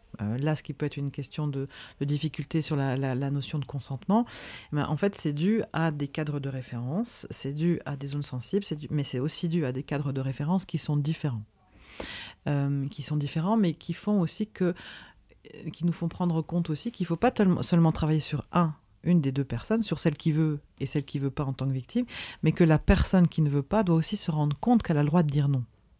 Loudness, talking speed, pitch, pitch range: -28 LUFS, 245 wpm, 150 Hz, 140-170 Hz